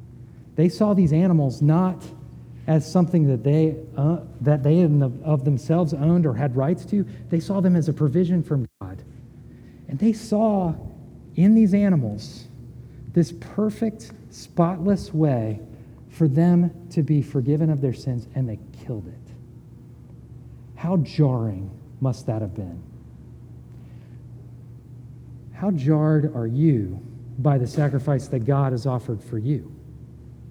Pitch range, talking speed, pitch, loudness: 120-165 Hz, 135 wpm, 145 Hz, -22 LUFS